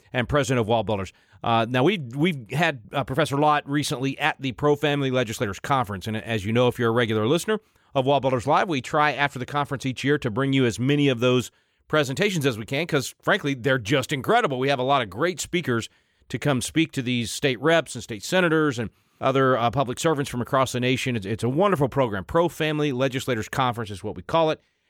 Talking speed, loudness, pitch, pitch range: 230 wpm, -23 LUFS, 135 Hz, 120-150 Hz